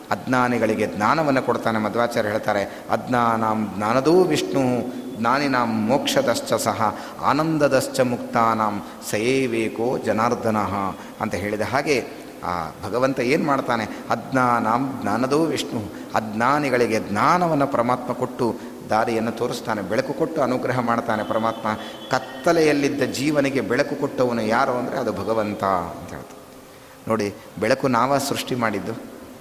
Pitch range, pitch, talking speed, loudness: 110-130 Hz, 120 Hz, 105 wpm, -22 LUFS